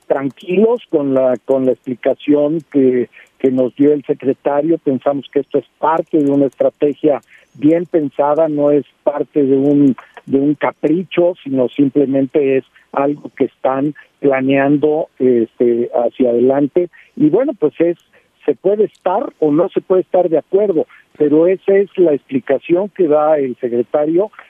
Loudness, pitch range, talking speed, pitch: -15 LUFS, 135-165 Hz, 155 wpm, 145 Hz